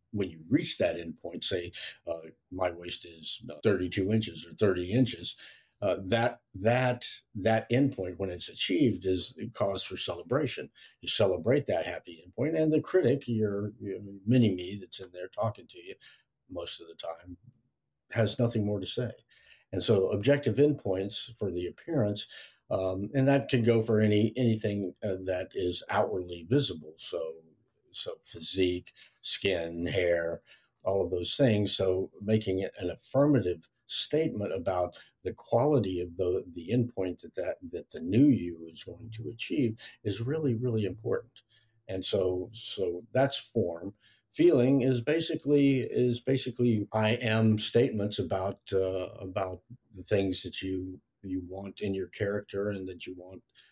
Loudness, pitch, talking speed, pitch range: -30 LUFS, 105 Hz, 155 wpm, 95-125 Hz